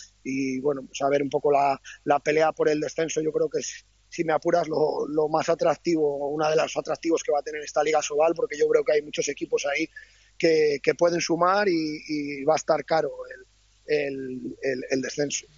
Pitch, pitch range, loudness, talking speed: 155 Hz, 145-175 Hz, -25 LUFS, 220 wpm